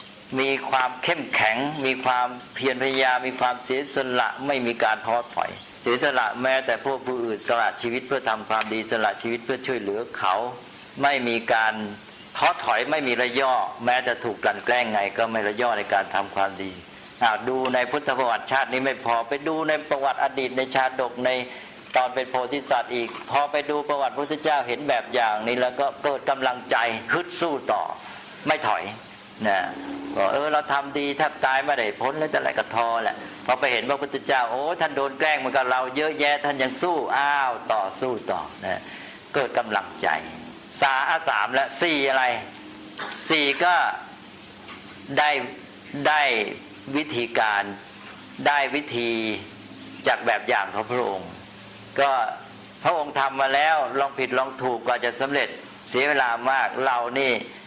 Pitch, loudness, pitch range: 130 Hz, -24 LUFS, 115-140 Hz